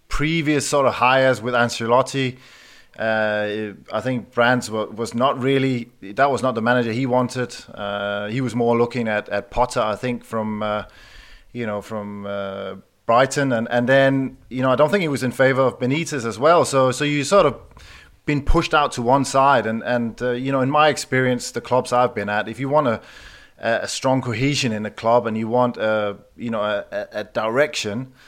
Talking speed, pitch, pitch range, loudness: 210 wpm, 125 Hz, 110-135 Hz, -20 LUFS